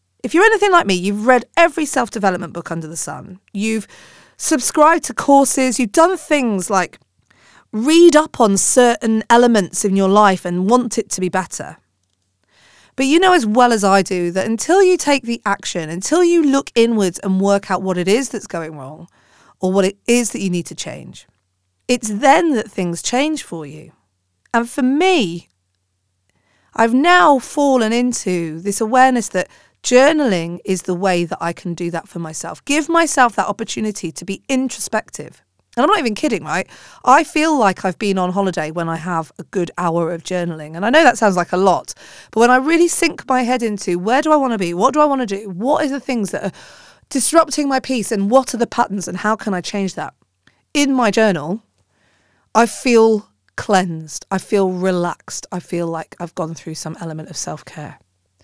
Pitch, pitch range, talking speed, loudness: 205 Hz, 175-255 Hz, 200 wpm, -16 LUFS